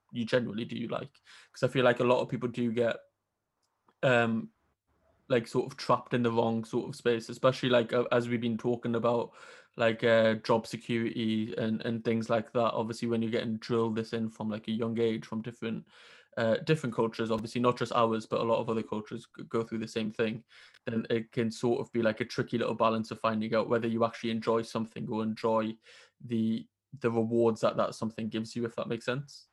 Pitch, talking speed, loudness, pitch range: 115 Hz, 220 wpm, -31 LUFS, 115-120 Hz